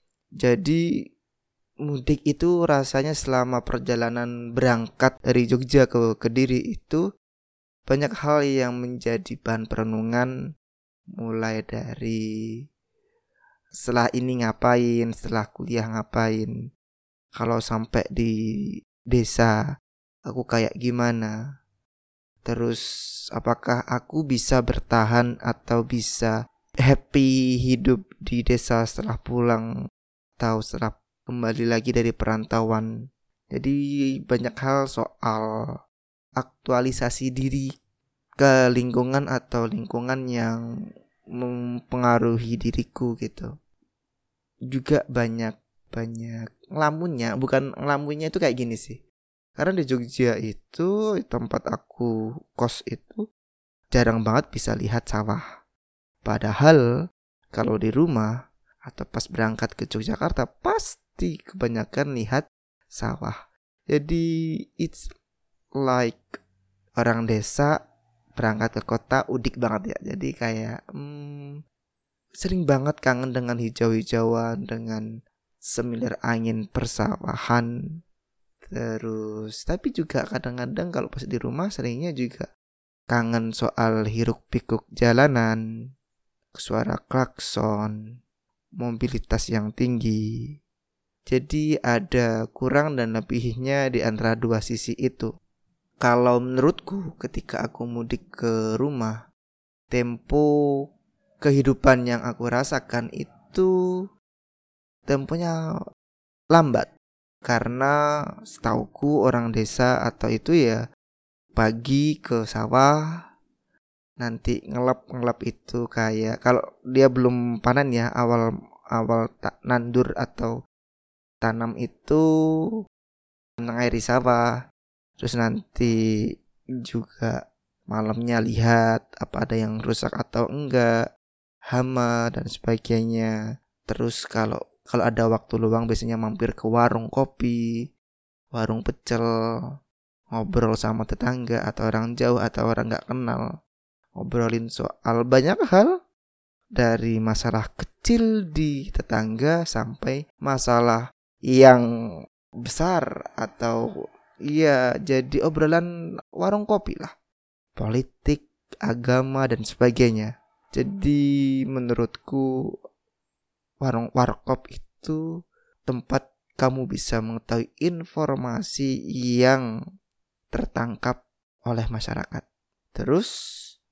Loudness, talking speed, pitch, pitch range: -24 LUFS, 95 wpm, 120 Hz, 115-130 Hz